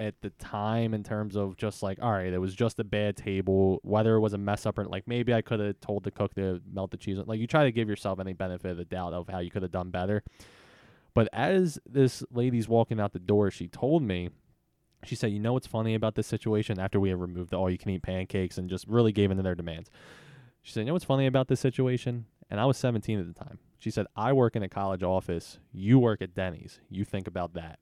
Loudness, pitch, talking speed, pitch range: -29 LUFS, 105 Hz, 265 wpm, 95-115 Hz